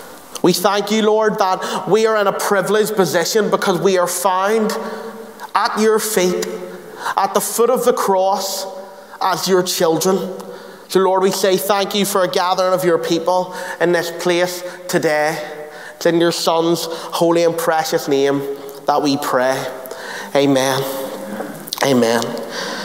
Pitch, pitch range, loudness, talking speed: 180 Hz, 165-195 Hz, -17 LUFS, 145 wpm